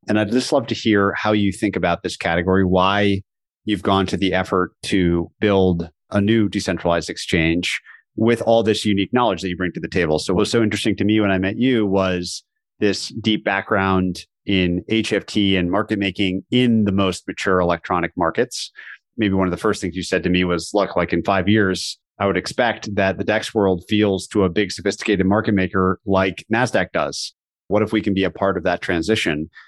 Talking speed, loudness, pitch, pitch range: 210 wpm, -19 LUFS, 95 Hz, 90-105 Hz